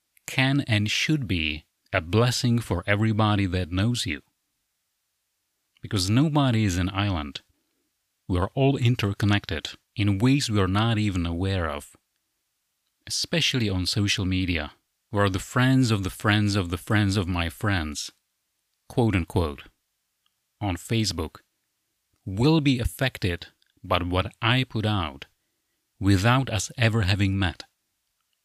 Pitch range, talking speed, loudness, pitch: 95-115 Hz, 130 wpm, -25 LUFS, 100 Hz